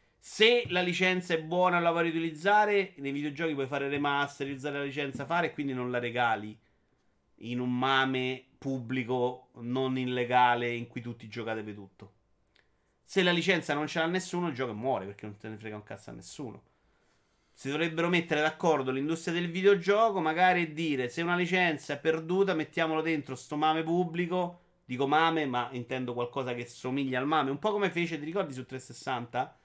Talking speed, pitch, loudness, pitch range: 180 wpm, 145 Hz, -29 LUFS, 125-175 Hz